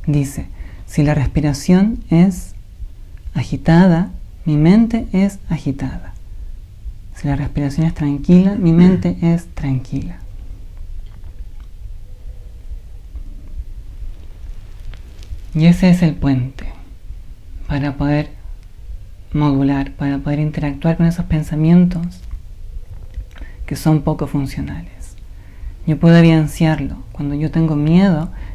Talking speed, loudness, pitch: 90 wpm, -16 LUFS, 140 Hz